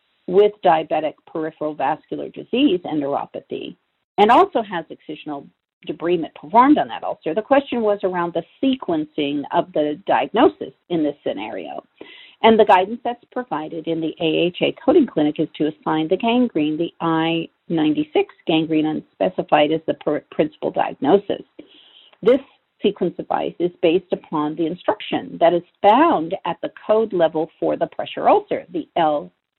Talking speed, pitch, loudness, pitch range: 150 wpm, 175 Hz, -20 LUFS, 160-250 Hz